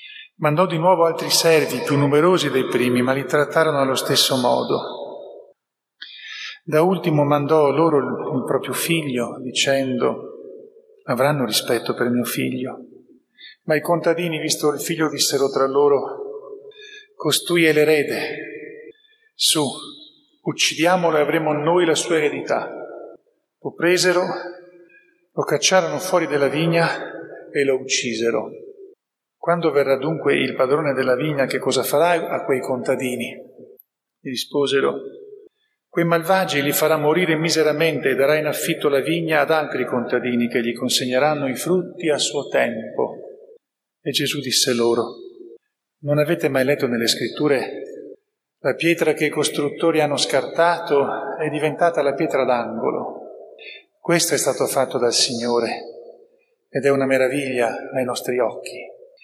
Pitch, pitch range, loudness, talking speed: 160 Hz, 140-190 Hz, -19 LUFS, 135 wpm